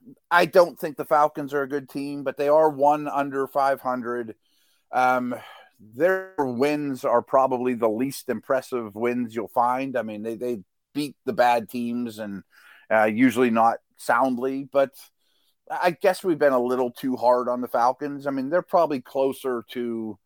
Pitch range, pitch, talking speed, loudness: 120-145 Hz, 130 Hz, 170 wpm, -24 LUFS